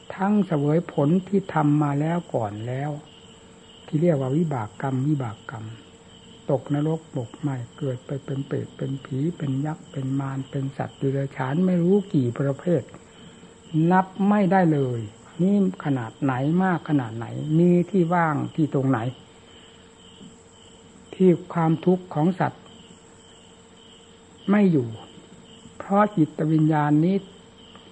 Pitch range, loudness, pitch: 135-175 Hz, -24 LUFS, 150 Hz